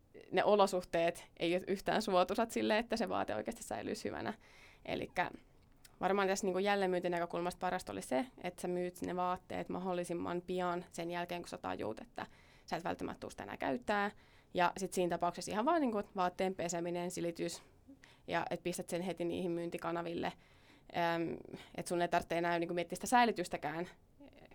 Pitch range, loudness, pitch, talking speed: 170-190 Hz, -37 LUFS, 180 Hz, 170 wpm